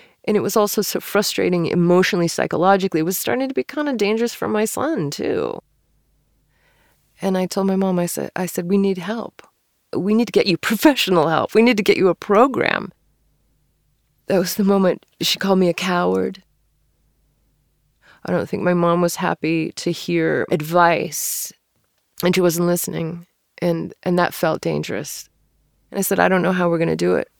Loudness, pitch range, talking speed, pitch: -19 LUFS, 175-205 Hz, 190 wpm, 185 Hz